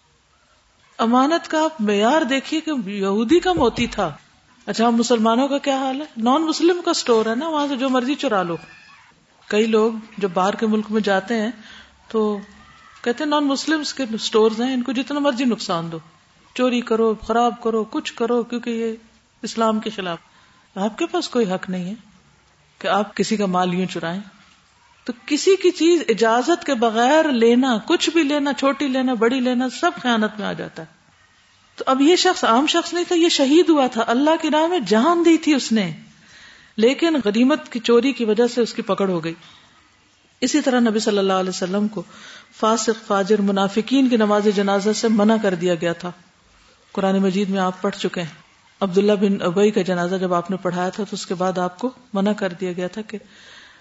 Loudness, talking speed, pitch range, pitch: -19 LUFS, 200 wpm, 200-270 Hz, 225 Hz